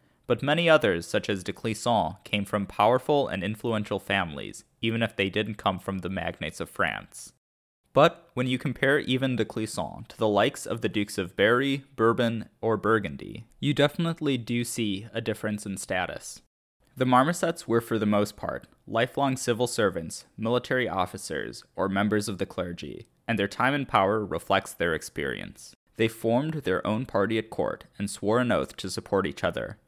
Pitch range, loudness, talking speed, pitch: 100-125 Hz, -27 LUFS, 180 wpm, 110 Hz